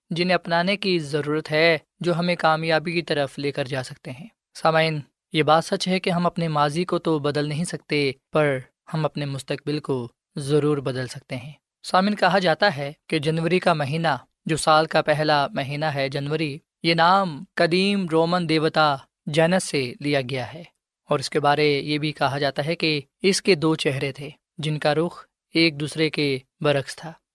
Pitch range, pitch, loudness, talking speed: 145-170 Hz, 155 Hz, -22 LUFS, 190 wpm